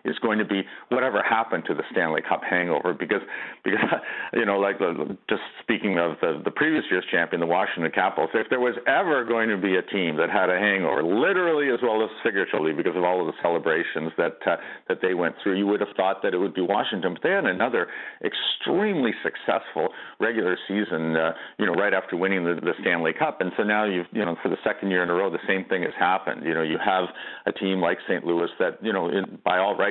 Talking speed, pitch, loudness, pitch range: 240 wpm, 95 Hz, -24 LUFS, 90-105 Hz